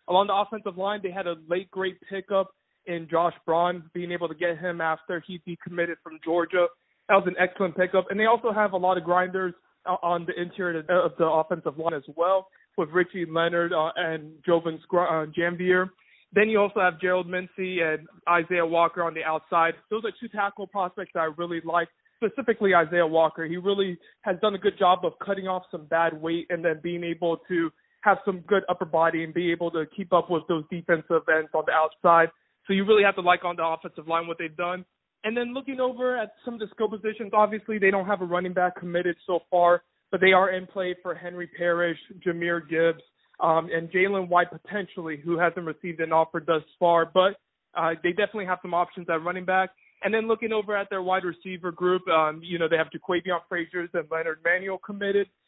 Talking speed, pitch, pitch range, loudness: 215 wpm, 175 Hz, 170-190 Hz, -26 LUFS